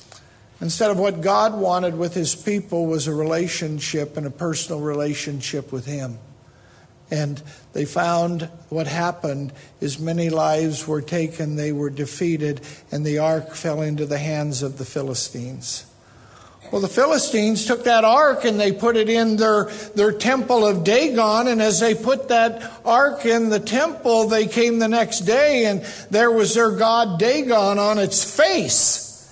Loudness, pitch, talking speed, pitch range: -20 LUFS, 175 Hz, 160 wpm, 150-220 Hz